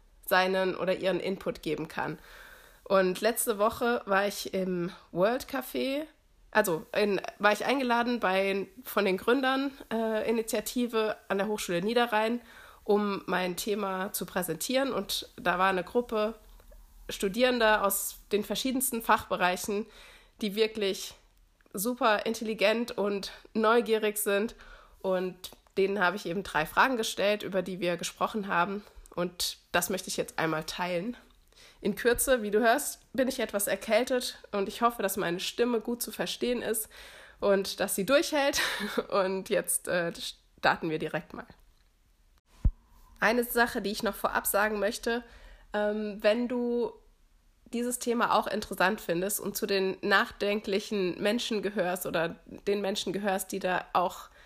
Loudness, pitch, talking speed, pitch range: -29 LUFS, 205 Hz, 140 wpm, 190-230 Hz